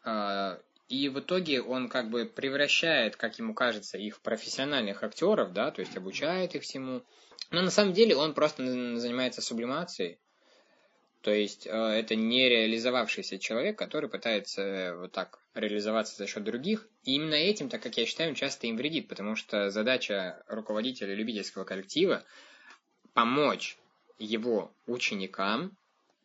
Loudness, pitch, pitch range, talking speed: -30 LUFS, 120 Hz, 105-140 Hz, 135 wpm